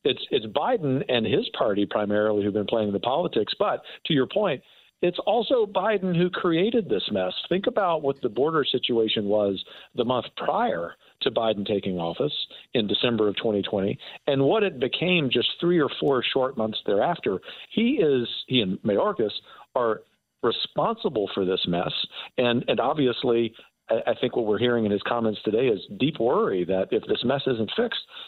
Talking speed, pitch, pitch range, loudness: 180 wpm, 115 Hz, 105-140 Hz, -25 LUFS